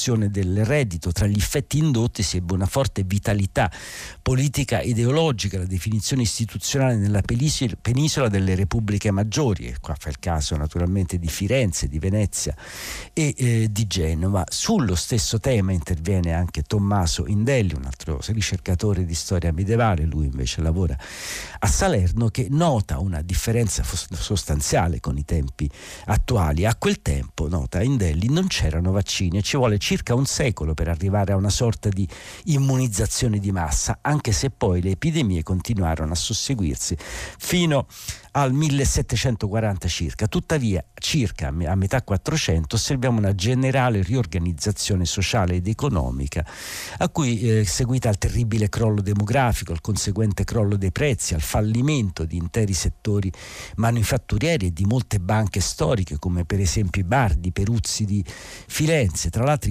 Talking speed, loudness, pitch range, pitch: 145 wpm, -22 LUFS, 90-120 Hz, 100 Hz